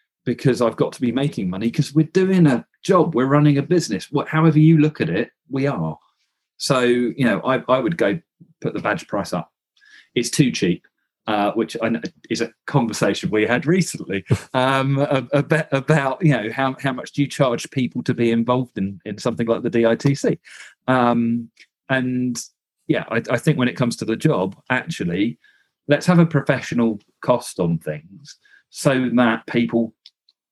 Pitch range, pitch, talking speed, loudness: 120-145 Hz, 130 Hz, 185 wpm, -20 LUFS